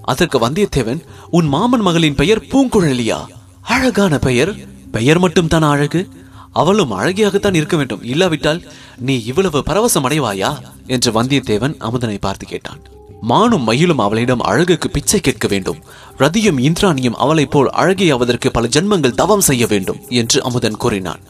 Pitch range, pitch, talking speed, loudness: 120-180 Hz, 145 Hz, 130 wpm, -15 LUFS